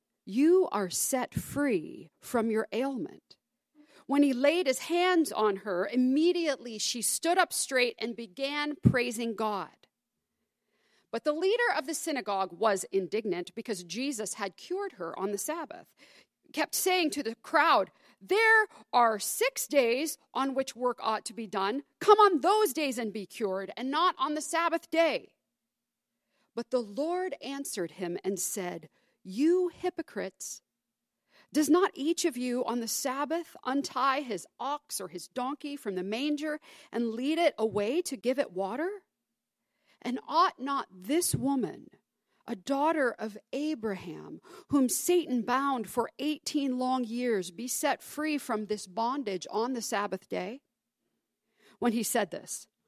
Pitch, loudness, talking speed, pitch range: 255 Hz, -30 LUFS, 150 wpm, 220-305 Hz